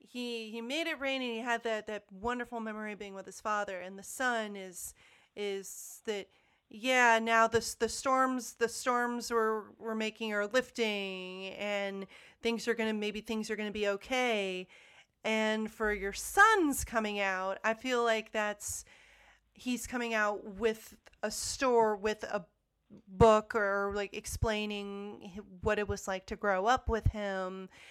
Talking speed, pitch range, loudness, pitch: 165 wpm, 205-230 Hz, -32 LUFS, 215 Hz